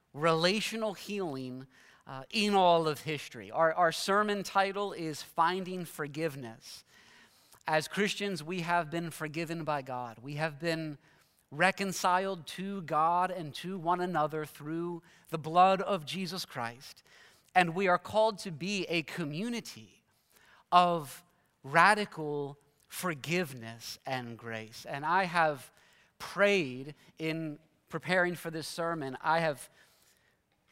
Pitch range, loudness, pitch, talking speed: 150-185 Hz, -31 LUFS, 165 Hz, 120 wpm